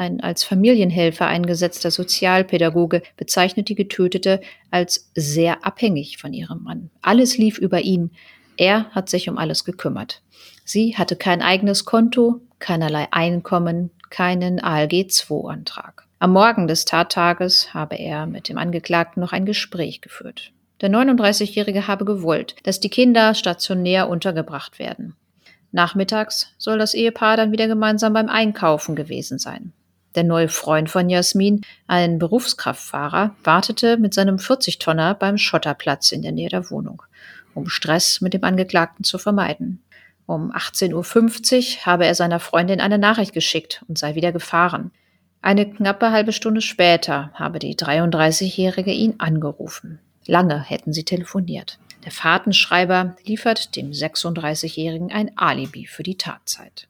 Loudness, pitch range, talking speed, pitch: -19 LUFS, 170-210 Hz, 140 wpm, 185 Hz